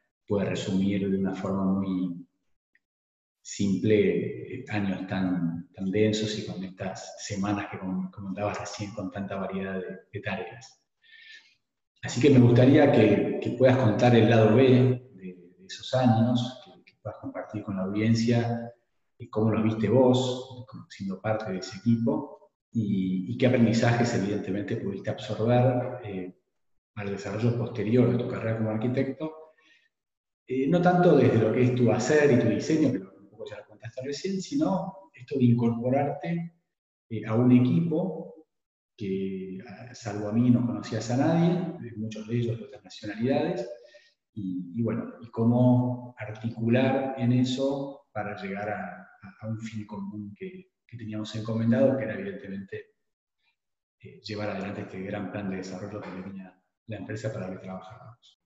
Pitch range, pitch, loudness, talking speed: 100-125 Hz, 110 Hz, -26 LUFS, 160 wpm